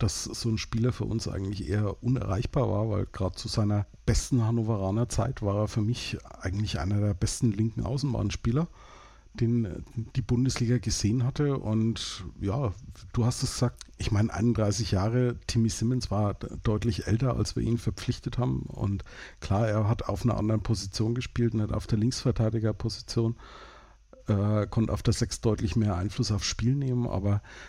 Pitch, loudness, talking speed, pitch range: 110 Hz, -29 LUFS, 170 wpm, 105-120 Hz